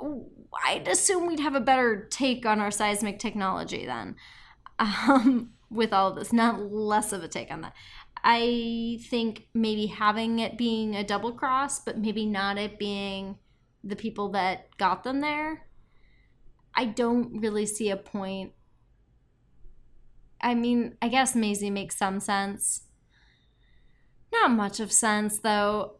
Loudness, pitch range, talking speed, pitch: -27 LUFS, 205-235 Hz, 150 wpm, 215 Hz